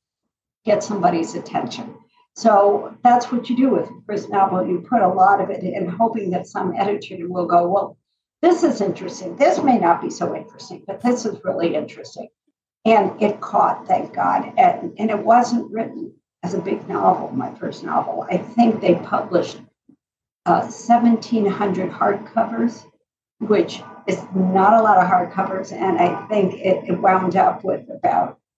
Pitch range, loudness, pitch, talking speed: 185-235 Hz, -19 LUFS, 205 Hz, 170 wpm